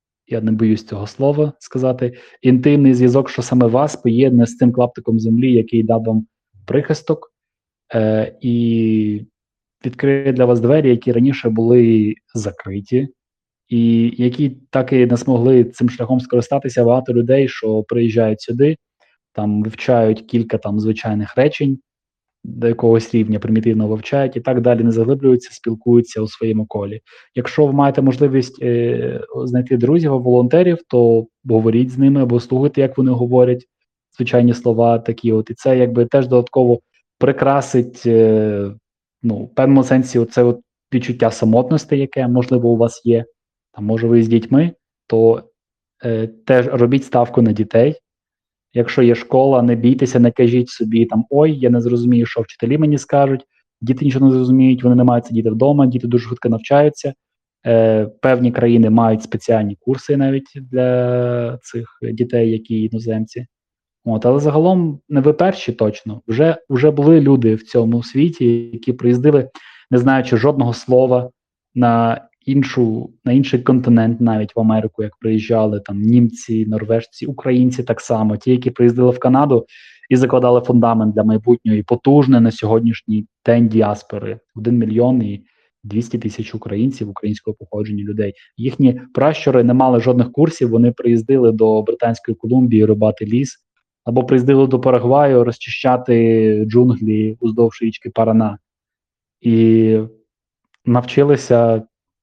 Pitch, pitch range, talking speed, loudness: 120 Hz, 115-130 Hz, 145 wpm, -15 LUFS